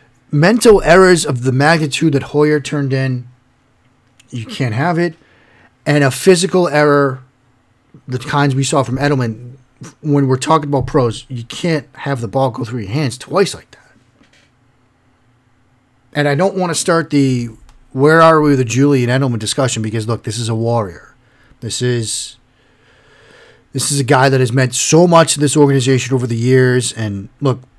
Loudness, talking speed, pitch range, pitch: -14 LUFS, 170 wpm, 125-145 Hz, 130 Hz